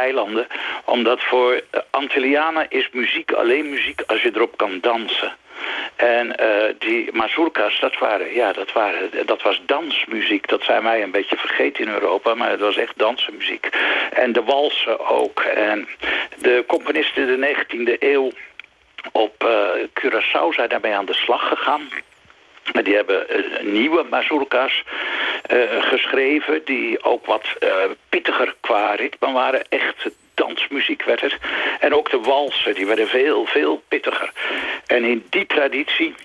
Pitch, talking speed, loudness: 390 Hz, 145 wpm, -19 LUFS